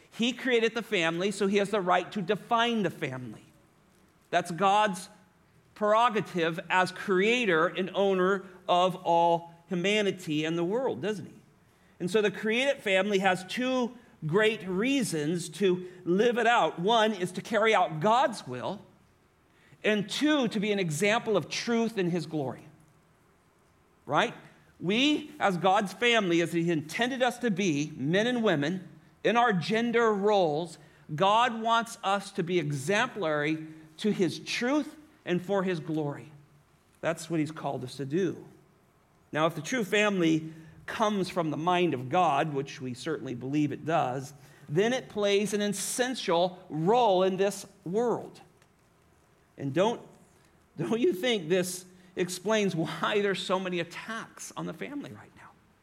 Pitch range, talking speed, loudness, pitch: 165-215 Hz, 150 wpm, -28 LUFS, 185 Hz